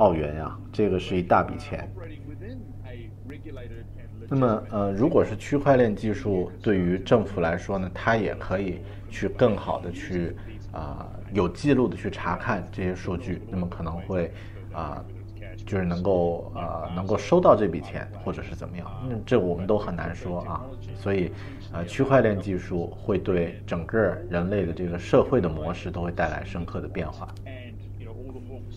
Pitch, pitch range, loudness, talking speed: 100 Hz, 90-105 Hz, -26 LUFS, 245 characters per minute